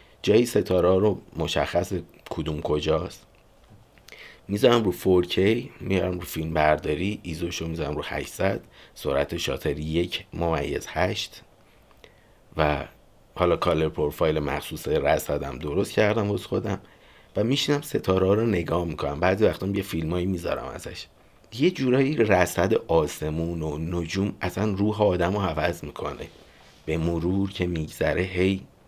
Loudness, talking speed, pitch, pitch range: -25 LUFS, 130 wpm, 90 Hz, 80-100 Hz